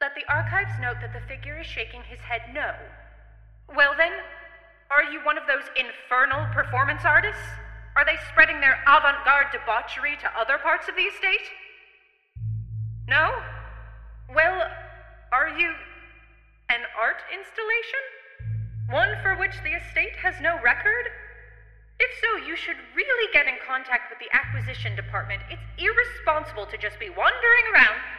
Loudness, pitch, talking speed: -23 LUFS, 310 Hz, 145 wpm